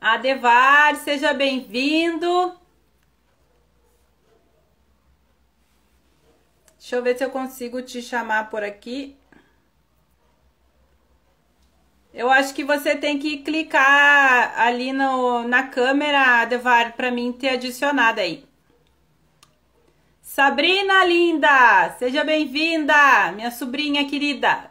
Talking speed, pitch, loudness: 90 wpm, 250 Hz, -18 LUFS